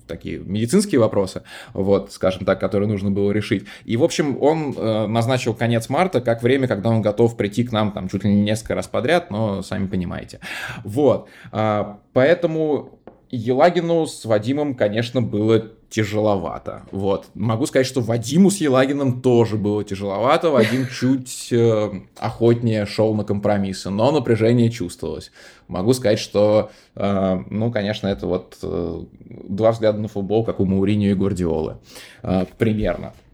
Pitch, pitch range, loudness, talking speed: 110 Hz, 100-120 Hz, -20 LUFS, 145 wpm